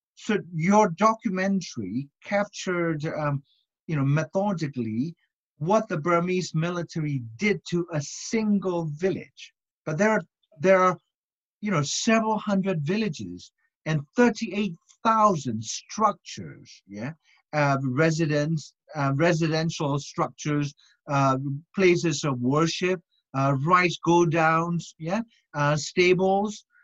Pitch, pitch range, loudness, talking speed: 170 Hz, 150-200 Hz, -25 LUFS, 105 wpm